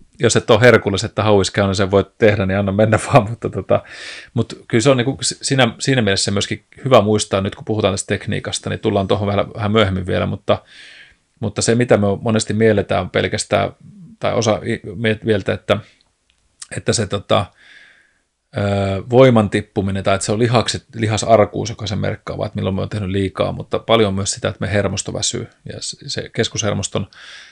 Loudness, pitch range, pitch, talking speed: -17 LUFS, 100-115 Hz, 105 Hz, 185 wpm